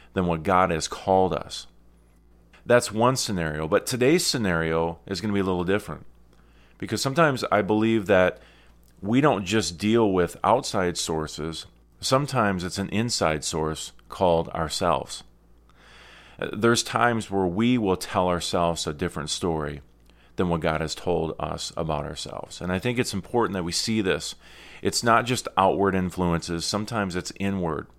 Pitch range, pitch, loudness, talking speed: 80-105 Hz, 90 Hz, -24 LUFS, 155 wpm